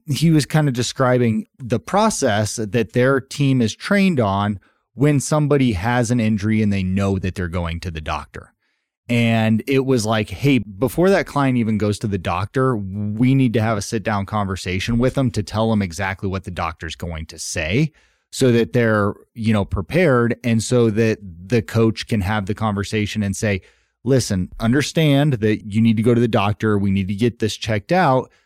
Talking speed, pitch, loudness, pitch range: 200 wpm, 110 Hz, -19 LUFS, 100-125 Hz